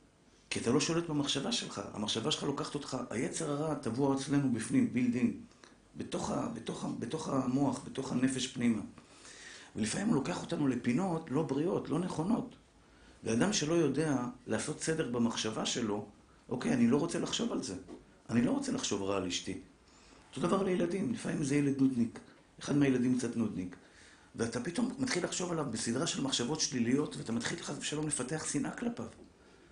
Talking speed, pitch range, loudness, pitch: 160 wpm, 120-170 Hz, -34 LUFS, 145 Hz